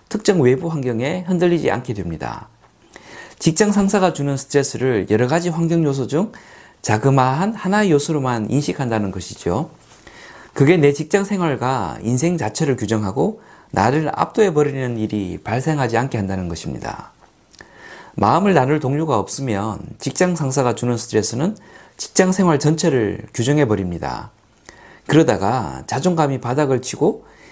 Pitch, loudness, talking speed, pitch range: 140 Hz, -19 LUFS, 320 characters per minute, 115-165 Hz